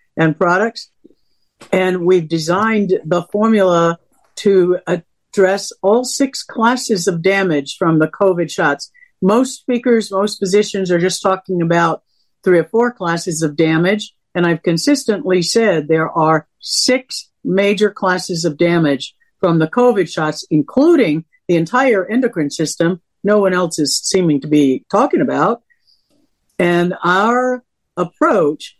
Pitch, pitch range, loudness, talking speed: 185 Hz, 170-220 Hz, -15 LUFS, 135 wpm